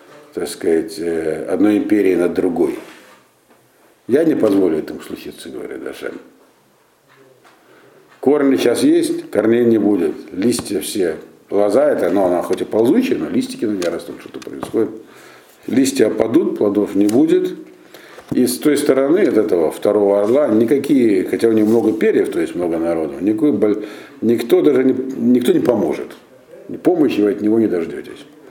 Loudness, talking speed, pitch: -16 LUFS, 150 wpm, 130 Hz